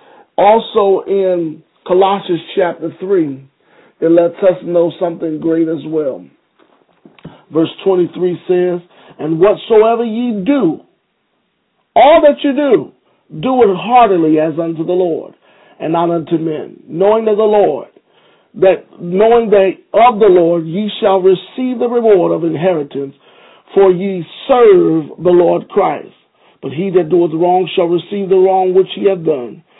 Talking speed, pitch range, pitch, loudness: 145 wpm, 170-215 Hz, 185 Hz, -12 LUFS